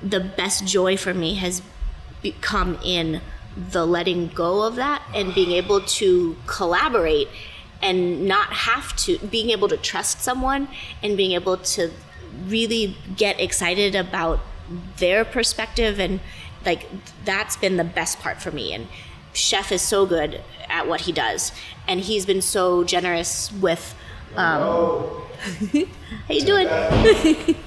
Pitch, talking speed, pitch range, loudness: 195 Hz, 140 wpm, 180-230 Hz, -21 LUFS